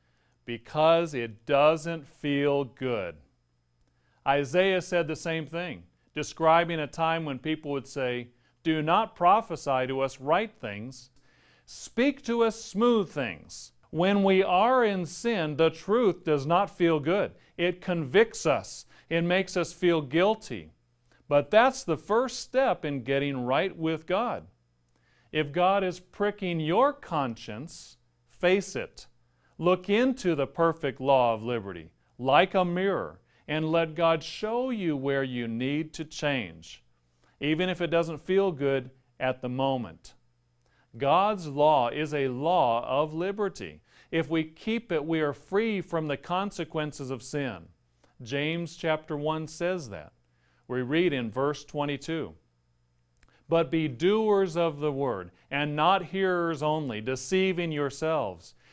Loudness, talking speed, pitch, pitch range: -27 LUFS, 140 wpm, 155 Hz, 130-175 Hz